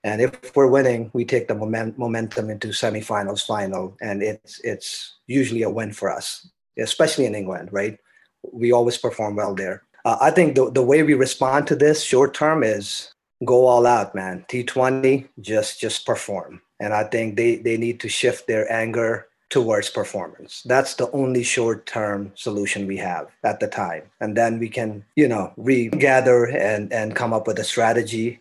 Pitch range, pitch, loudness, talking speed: 105-130 Hz, 115 Hz, -21 LUFS, 180 wpm